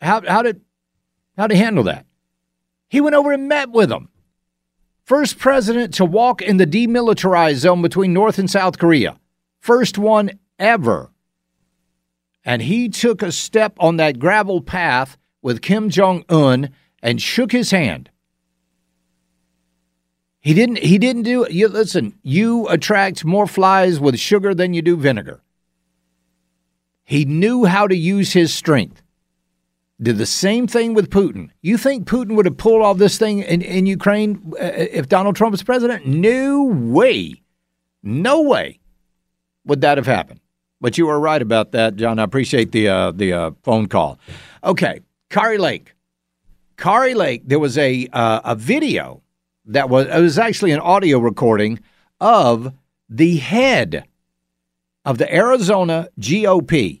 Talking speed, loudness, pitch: 150 wpm, -16 LUFS, 165 Hz